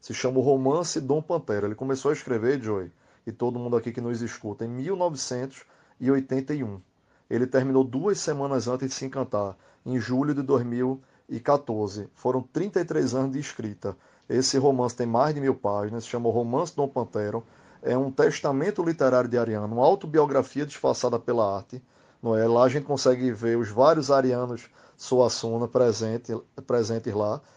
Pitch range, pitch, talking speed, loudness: 115-135 Hz, 125 Hz, 165 wpm, -26 LUFS